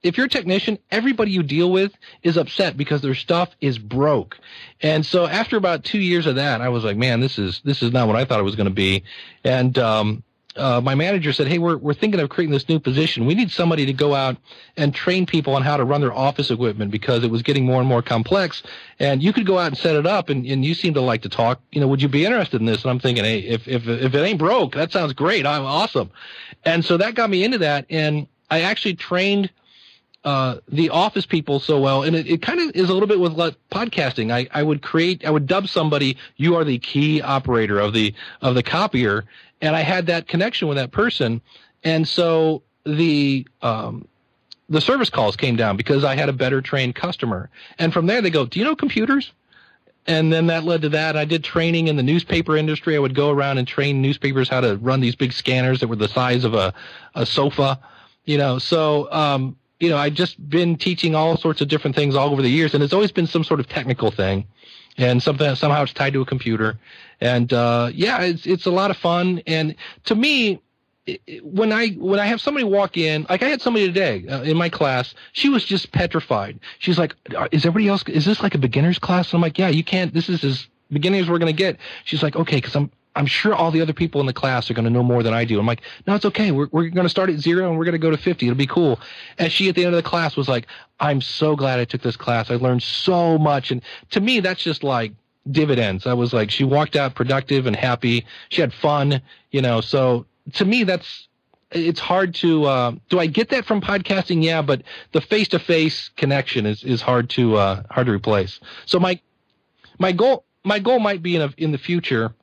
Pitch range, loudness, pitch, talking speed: 130-175 Hz, -19 LUFS, 150 Hz, 245 wpm